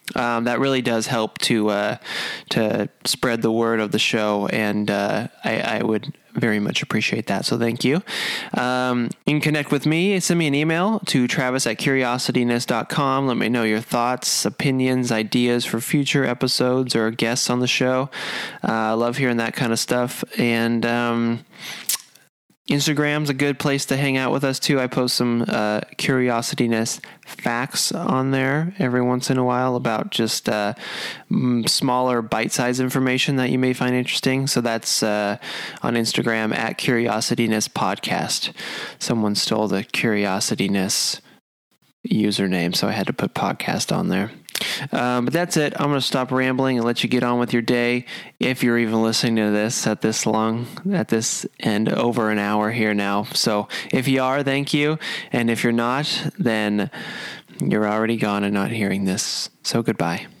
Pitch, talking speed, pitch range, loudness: 120 Hz, 175 wpm, 110-130 Hz, -21 LUFS